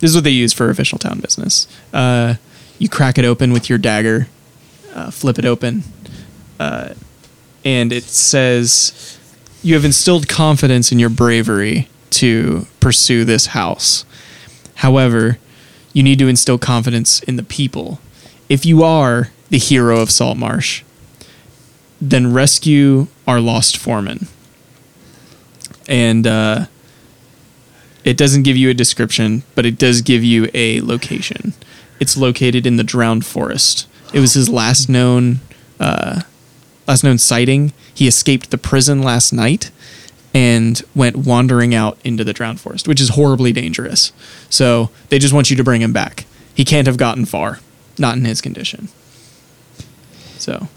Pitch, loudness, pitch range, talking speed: 125 Hz, -13 LUFS, 120-140 Hz, 150 wpm